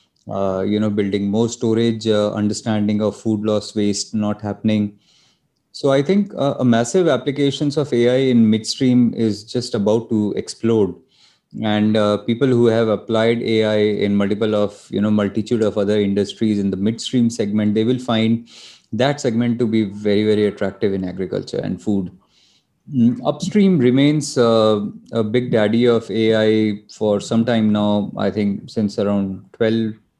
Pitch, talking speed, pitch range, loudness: 110 Hz, 165 wpm, 105-120 Hz, -18 LUFS